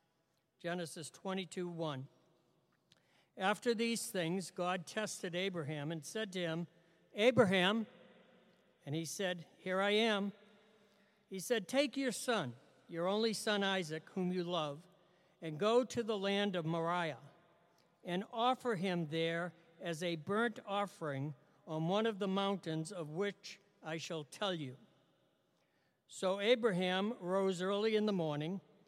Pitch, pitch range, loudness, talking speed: 185 Hz, 165-205 Hz, -37 LUFS, 135 wpm